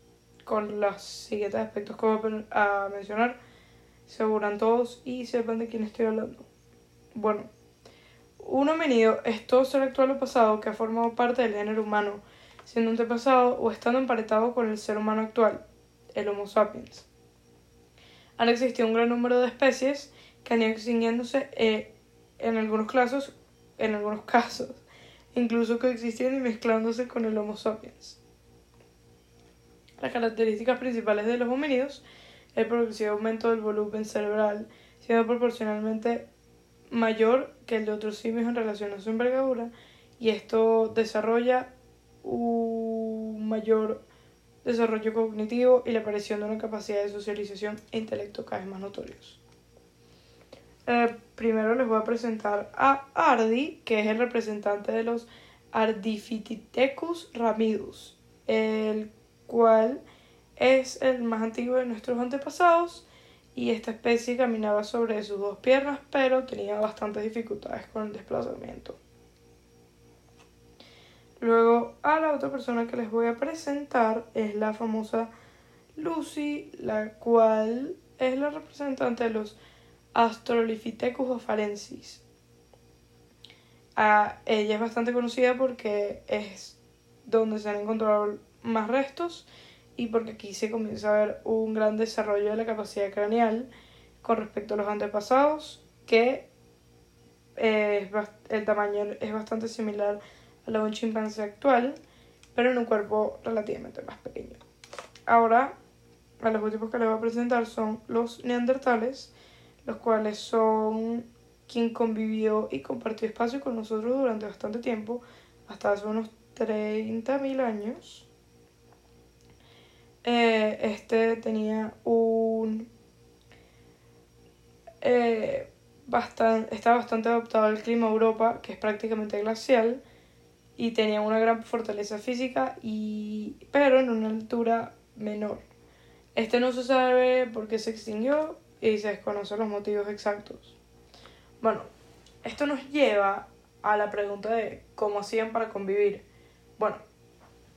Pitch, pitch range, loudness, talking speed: 225 Hz, 215-240 Hz, -27 LUFS, 125 wpm